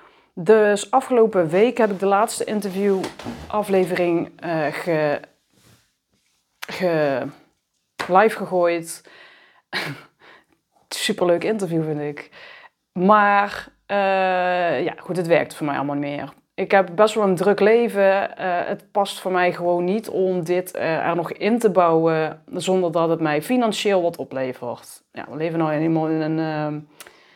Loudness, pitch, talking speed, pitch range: -20 LUFS, 180 Hz, 145 wpm, 165-205 Hz